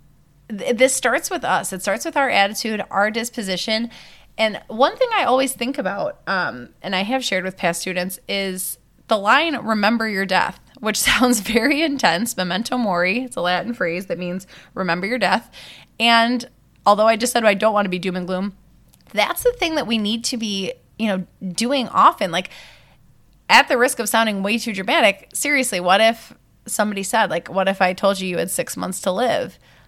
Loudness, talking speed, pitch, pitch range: -19 LUFS, 195 wpm, 215 Hz, 185-245 Hz